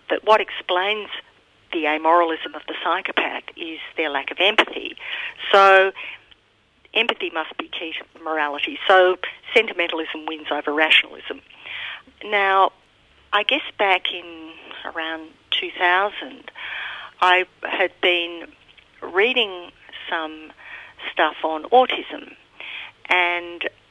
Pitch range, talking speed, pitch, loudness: 160-205 Hz, 105 wpm, 180 Hz, -20 LUFS